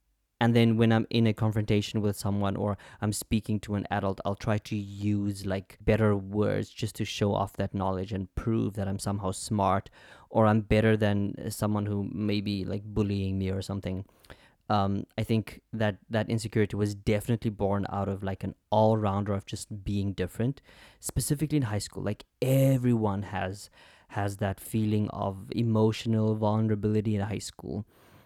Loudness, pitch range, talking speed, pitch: -29 LUFS, 100-110 Hz, 170 wpm, 105 Hz